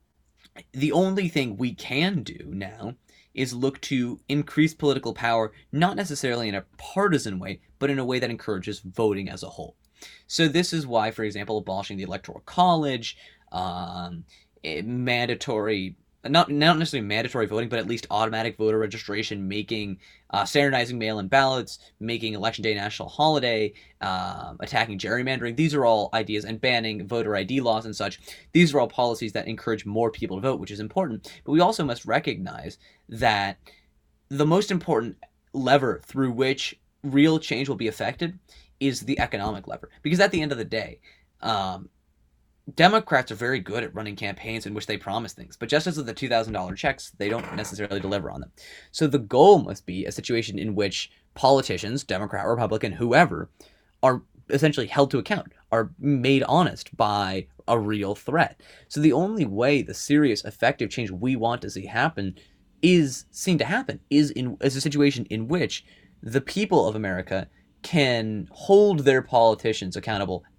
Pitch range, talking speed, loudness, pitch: 105-145 Hz, 170 wpm, -24 LUFS, 115 Hz